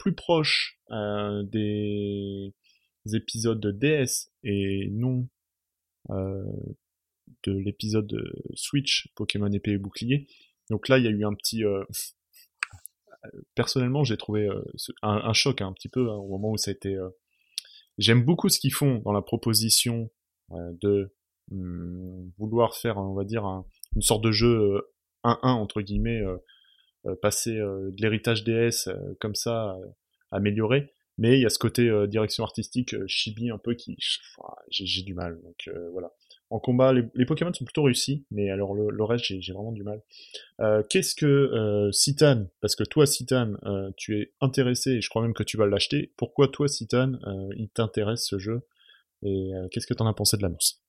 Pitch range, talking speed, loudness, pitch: 100-125 Hz, 190 wpm, -26 LUFS, 110 Hz